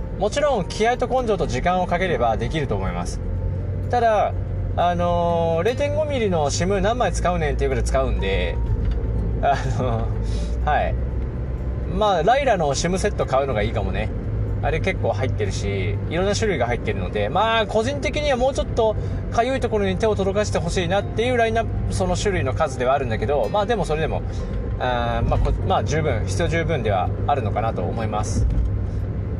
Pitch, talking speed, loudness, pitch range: 100 Hz, 380 characters per minute, -22 LUFS, 95-120 Hz